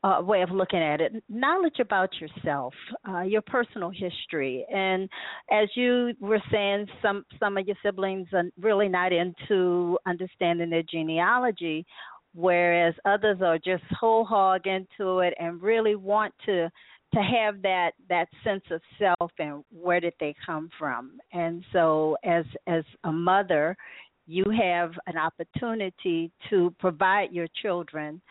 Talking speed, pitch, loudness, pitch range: 145 wpm, 185 Hz, -26 LUFS, 170-205 Hz